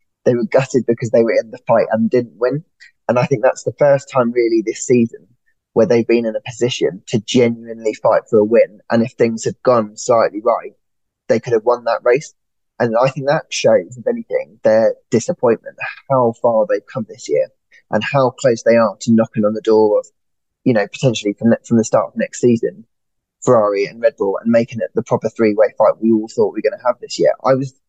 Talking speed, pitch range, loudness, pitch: 230 wpm, 110-130 Hz, -16 LUFS, 115 Hz